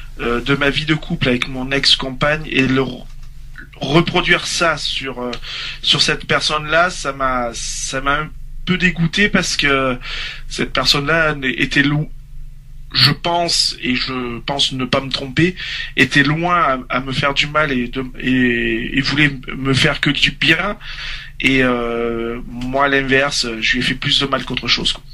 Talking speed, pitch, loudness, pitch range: 180 wpm, 140 Hz, -16 LUFS, 130-150 Hz